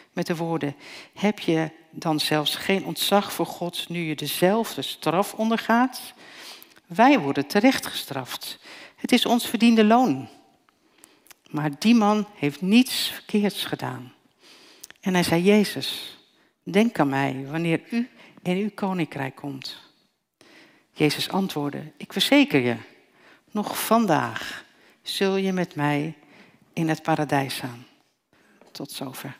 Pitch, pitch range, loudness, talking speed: 185 Hz, 150-225 Hz, -23 LUFS, 125 wpm